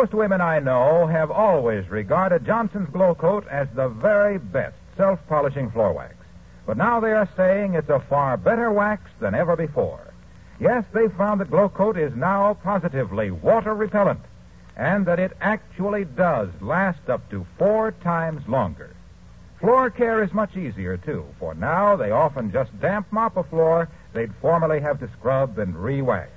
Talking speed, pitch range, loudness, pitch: 170 wpm, 140-205 Hz, -22 LUFS, 180 Hz